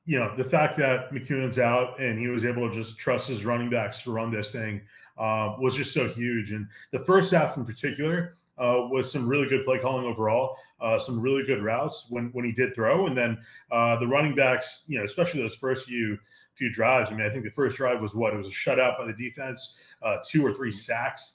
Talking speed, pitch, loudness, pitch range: 240 wpm, 125 Hz, -27 LUFS, 115-135 Hz